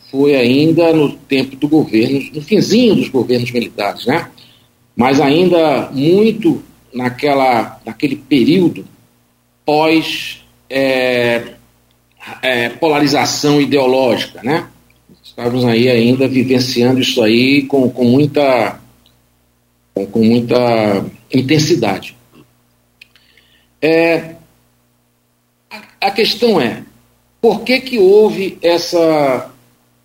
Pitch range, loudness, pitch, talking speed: 95-155 Hz, -13 LUFS, 130 Hz, 95 wpm